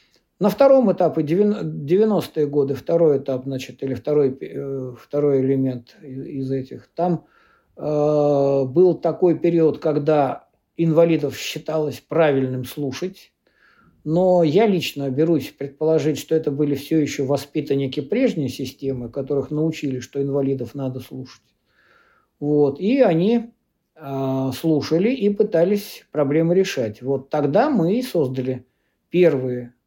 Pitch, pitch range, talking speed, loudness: 150 Hz, 135-170 Hz, 115 wpm, -20 LUFS